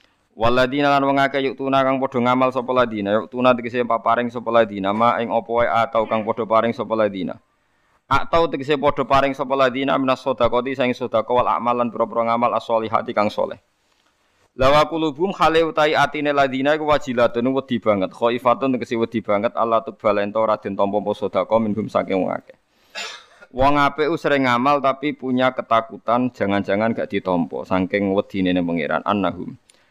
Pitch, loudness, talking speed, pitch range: 120 Hz, -20 LUFS, 165 wpm, 110-135 Hz